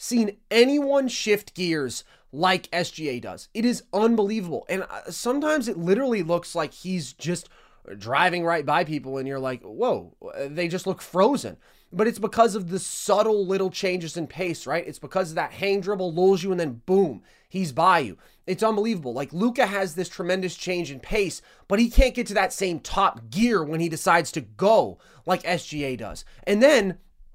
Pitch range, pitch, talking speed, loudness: 165-210 Hz, 185 Hz, 185 wpm, -24 LUFS